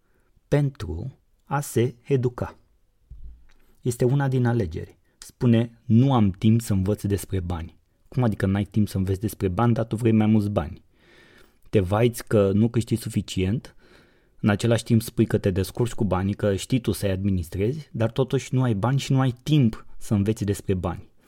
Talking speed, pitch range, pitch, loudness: 180 wpm, 100-120 Hz, 110 Hz, -24 LUFS